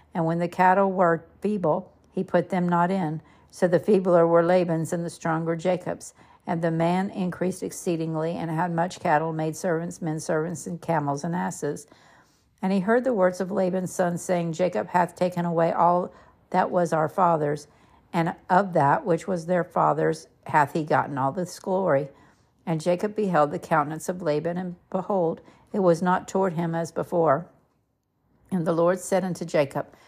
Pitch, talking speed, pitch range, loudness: 175 Hz, 180 wpm, 165-185 Hz, -25 LUFS